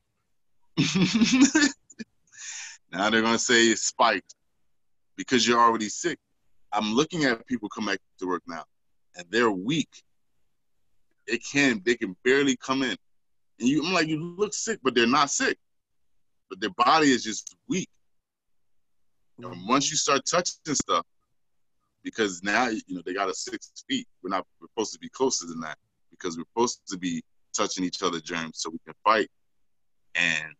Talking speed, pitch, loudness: 165 wpm, 135 Hz, -25 LUFS